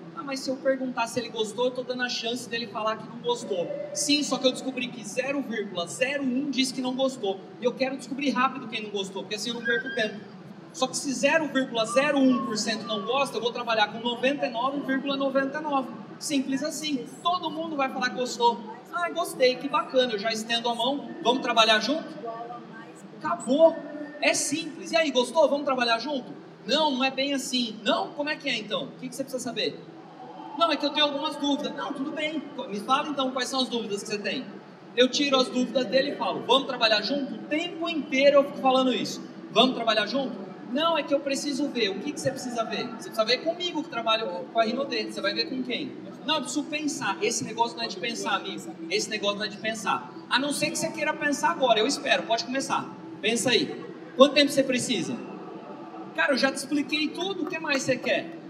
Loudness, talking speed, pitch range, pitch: -26 LUFS, 215 wpm, 235-290 Hz, 265 Hz